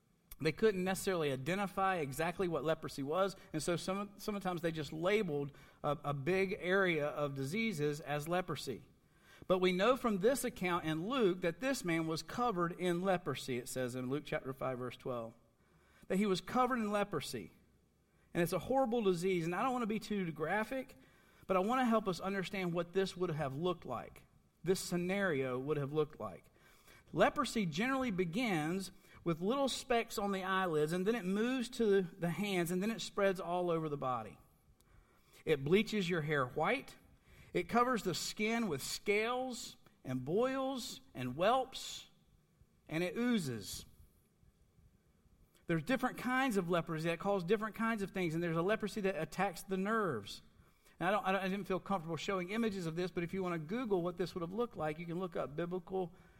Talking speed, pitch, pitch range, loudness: 185 wpm, 185 Hz, 160-205 Hz, -37 LUFS